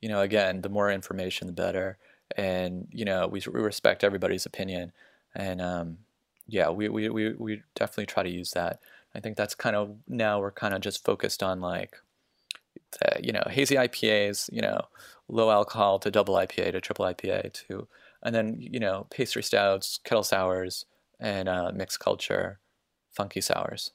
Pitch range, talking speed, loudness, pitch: 95-105 Hz, 175 wpm, -28 LUFS, 100 Hz